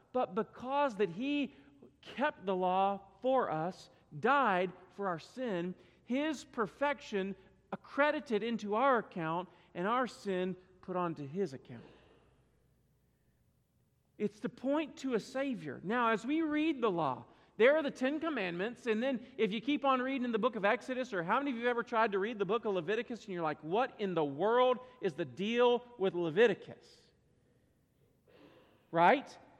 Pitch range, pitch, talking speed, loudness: 190-260 Hz, 225 Hz, 165 wpm, -34 LUFS